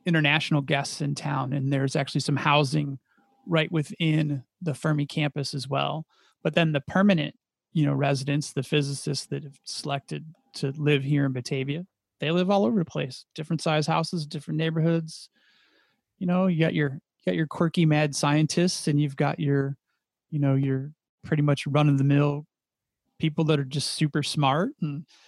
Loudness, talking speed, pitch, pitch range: -26 LUFS, 165 wpm, 150 Hz, 140-160 Hz